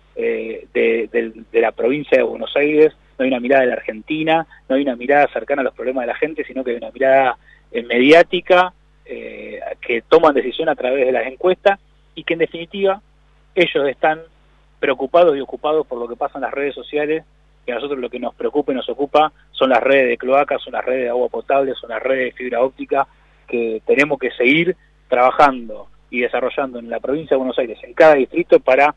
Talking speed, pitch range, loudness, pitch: 210 wpm, 135-185 Hz, -17 LUFS, 155 Hz